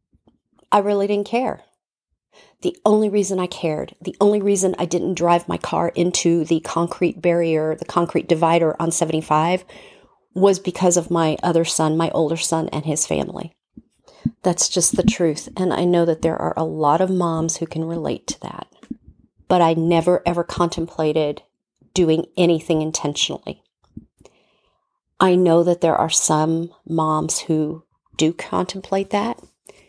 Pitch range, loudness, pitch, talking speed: 160-180 Hz, -19 LUFS, 170 Hz, 155 wpm